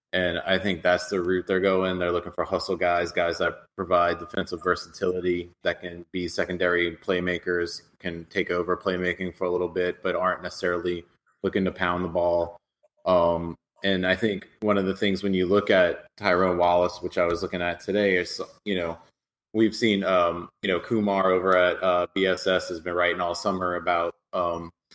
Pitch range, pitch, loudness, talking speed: 85-95 Hz, 90 Hz, -25 LUFS, 190 wpm